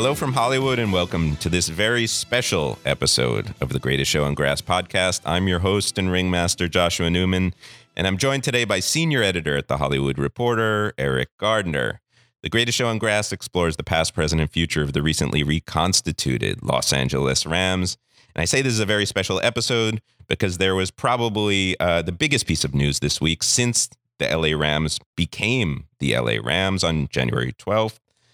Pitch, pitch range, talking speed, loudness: 90 Hz, 75-110 Hz, 185 wpm, -21 LUFS